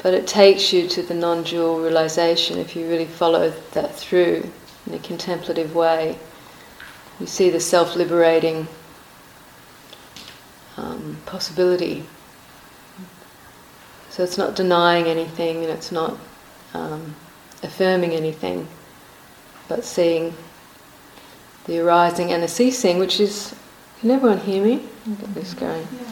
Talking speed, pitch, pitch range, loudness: 115 wpm, 170 Hz, 165-185 Hz, -20 LUFS